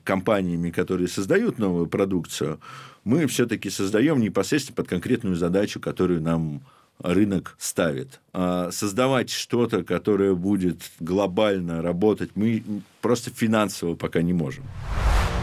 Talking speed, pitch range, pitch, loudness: 115 wpm, 90-105 Hz, 95 Hz, -24 LUFS